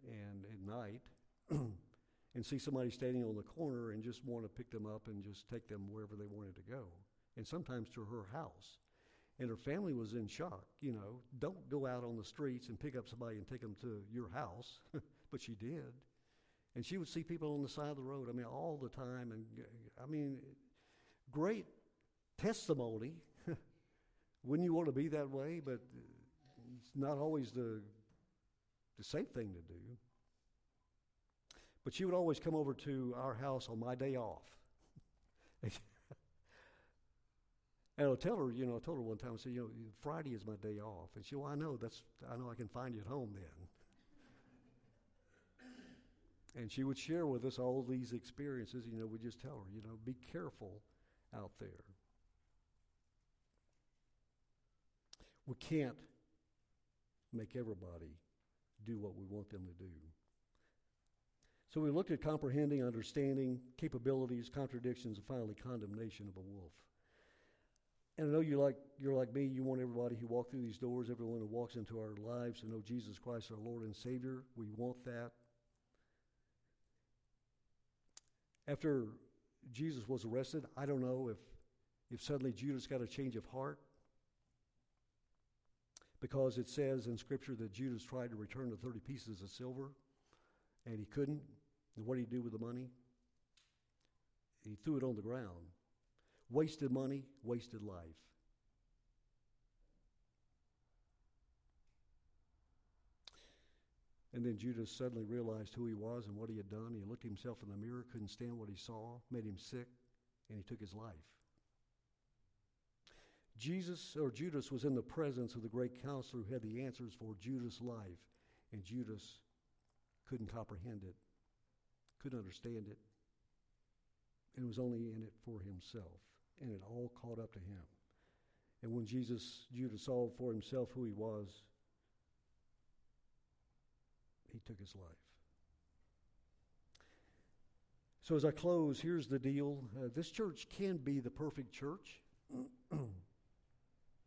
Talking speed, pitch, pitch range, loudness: 155 wpm, 120 Hz, 110-135 Hz, -45 LUFS